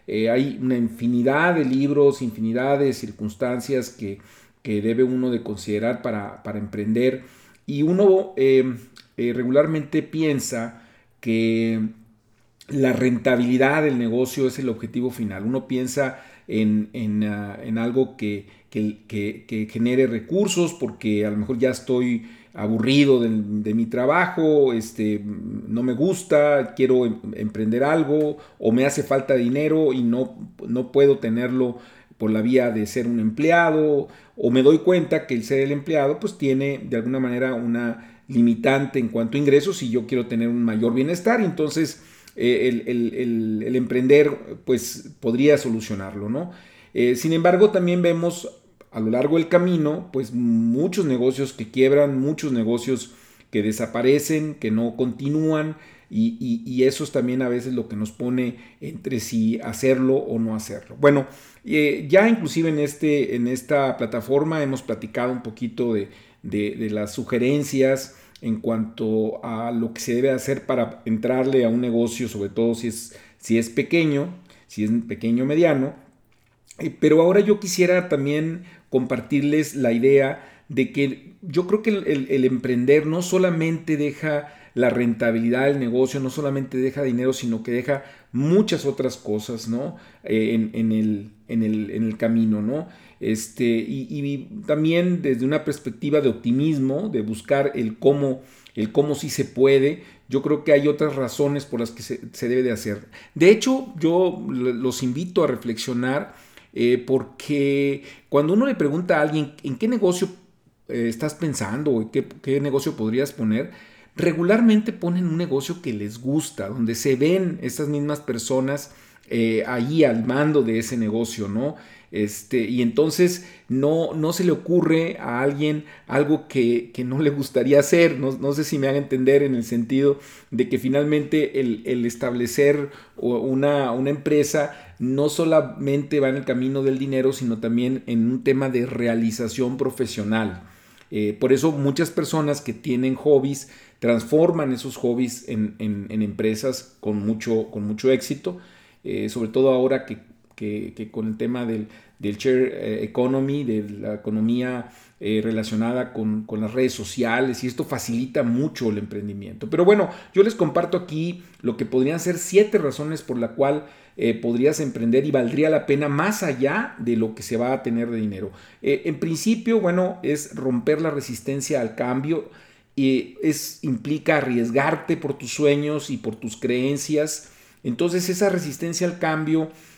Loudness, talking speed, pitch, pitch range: -22 LUFS, 165 wpm, 130 Hz, 115-150 Hz